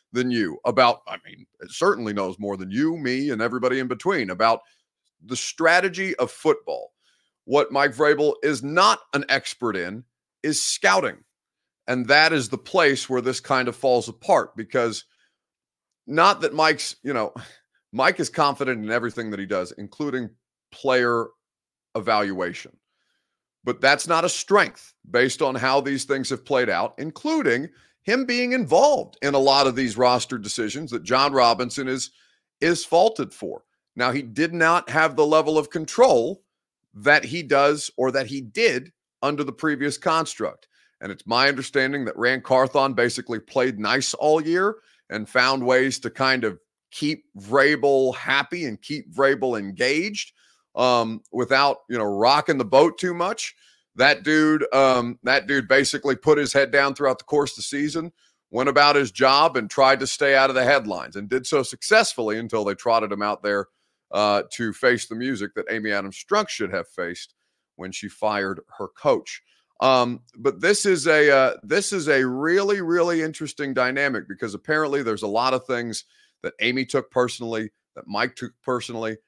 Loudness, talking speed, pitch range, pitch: -21 LUFS, 170 wpm, 120-150 Hz, 135 Hz